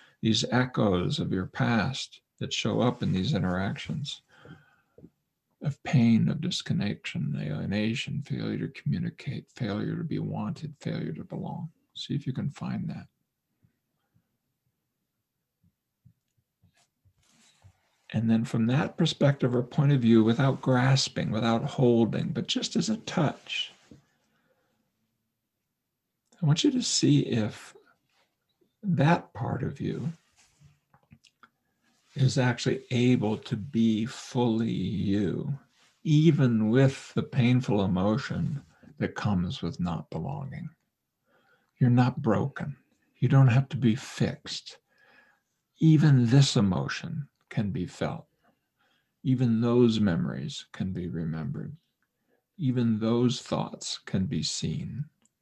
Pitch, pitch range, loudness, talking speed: 130 Hz, 115-150 Hz, -27 LUFS, 115 wpm